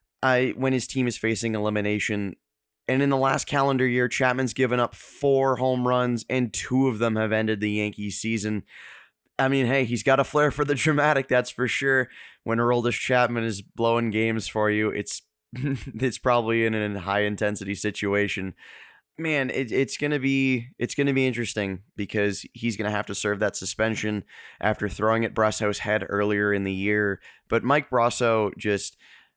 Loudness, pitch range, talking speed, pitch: -24 LUFS, 105-130 Hz, 180 wpm, 115 Hz